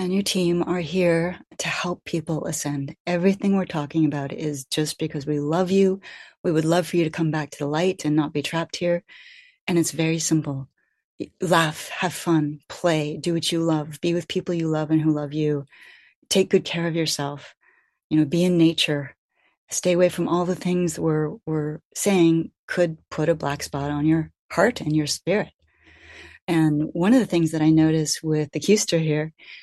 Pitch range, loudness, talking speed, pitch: 150-175 Hz, -23 LUFS, 200 wpm, 160 Hz